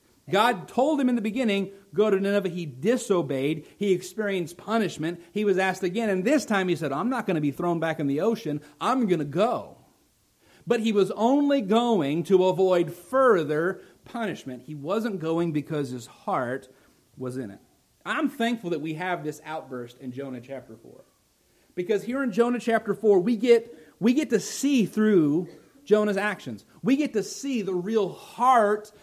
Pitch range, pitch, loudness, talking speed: 160-230 Hz, 195 Hz, -25 LUFS, 180 wpm